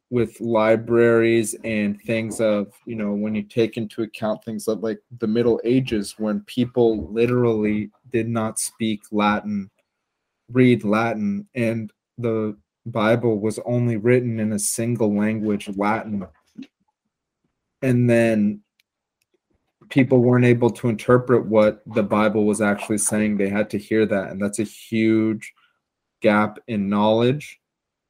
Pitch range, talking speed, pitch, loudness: 105-115 Hz, 135 wpm, 110 Hz, -21 LUFS